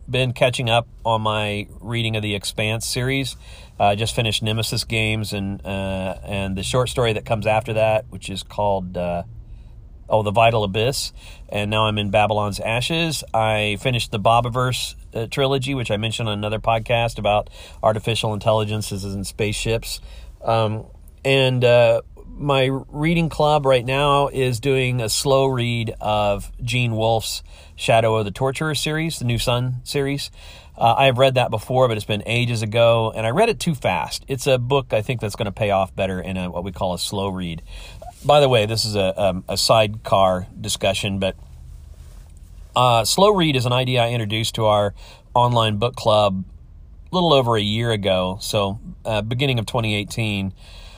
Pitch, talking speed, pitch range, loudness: 110 Hz, 180 wpm, 100-125 Hz, -20 LUFS